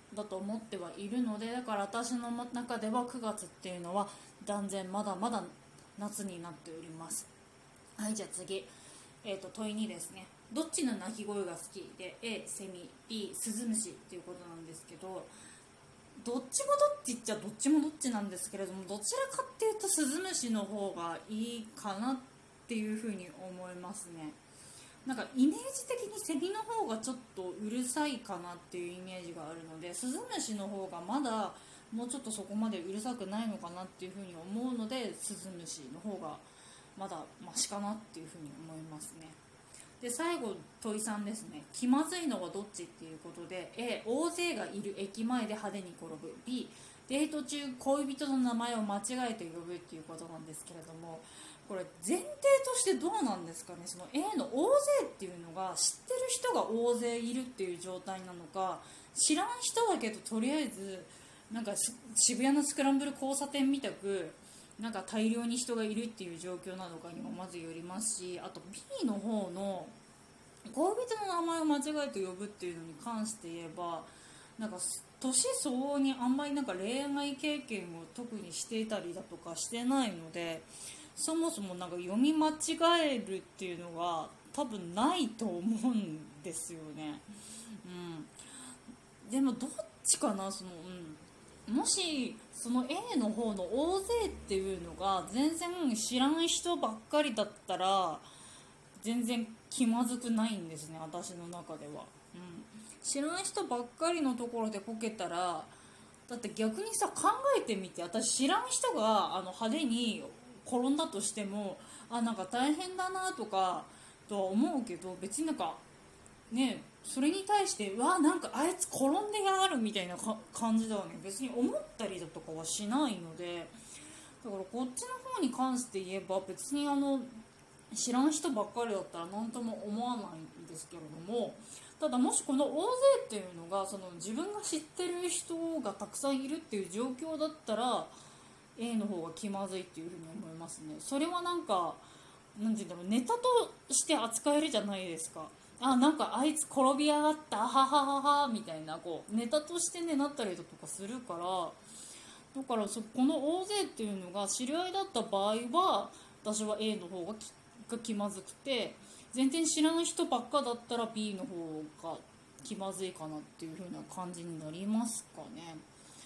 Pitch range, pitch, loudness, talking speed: 185-275 Hz, 220 Hz, -35 LUFS, 335 characters per minute